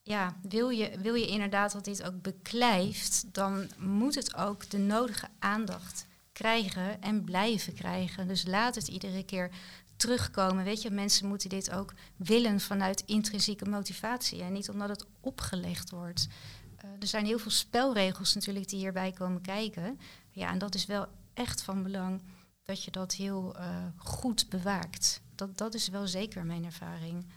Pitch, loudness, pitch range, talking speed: 195 Hz, -32 LUFS, 185-210 Hz, 165 wpm